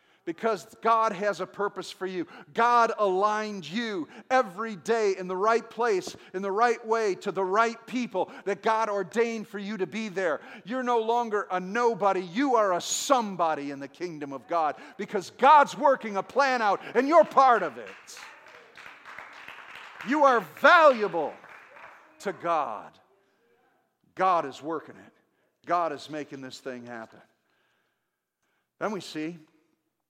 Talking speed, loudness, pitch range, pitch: 150 wpm, -26 LUFS, 185-235 Hz, 210 Hz